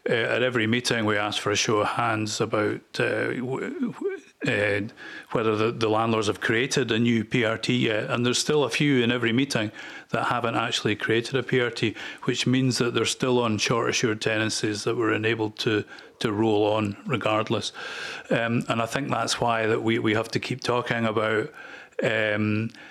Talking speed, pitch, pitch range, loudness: 190 wpm, 115 Hz, 110-125 Hz, -25 LUFS